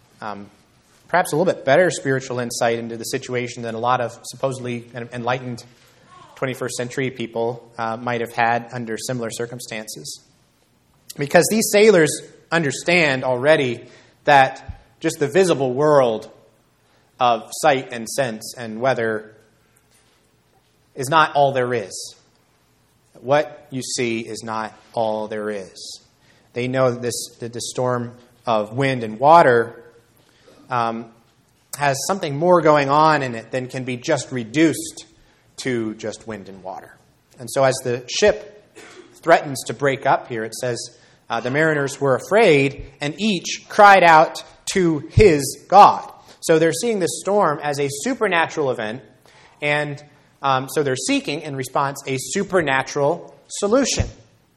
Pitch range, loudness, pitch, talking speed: 120-150 Hz, -19 LUFS, 130 Hz, 140 wpm